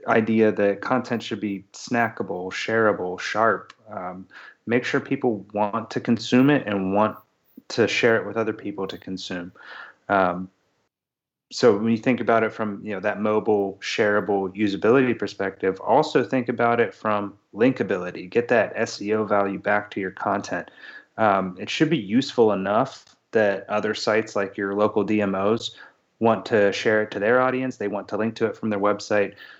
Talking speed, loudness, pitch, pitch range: 170 wpm, -23 LUFS, 105 Hz, 100-115 Hz